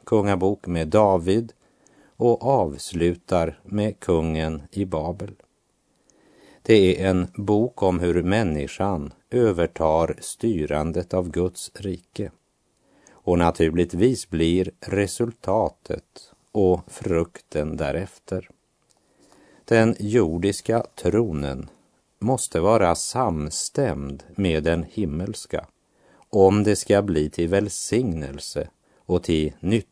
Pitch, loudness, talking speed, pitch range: 90 Hz, -23 LUFS, 90 wpm, 80-100 Hz